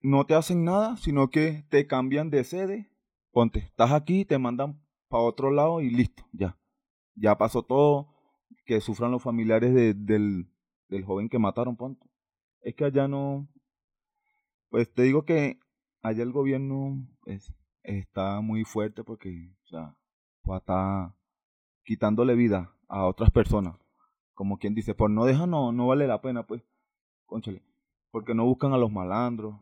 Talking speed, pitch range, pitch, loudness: 160 wpm, 105-140 Hz, 120 Hz, -26 LUFS